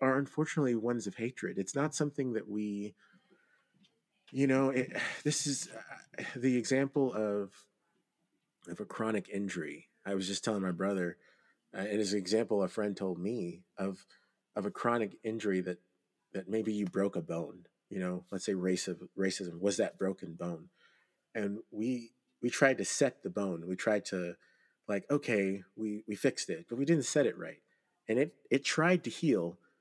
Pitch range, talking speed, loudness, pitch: 95-120 Hz, 180 wpm, -34 LUFS, 105 Hz